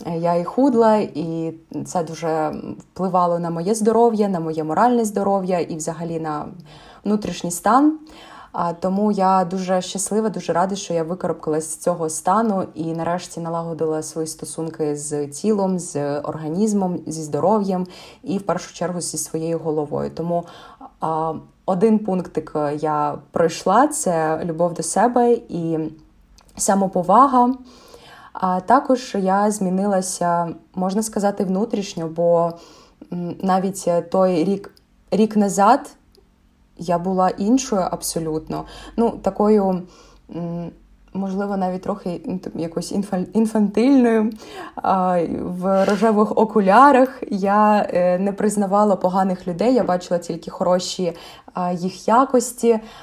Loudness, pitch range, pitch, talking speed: -20 LUFS, 165-210 Hz, 185 Hz, 110 wpm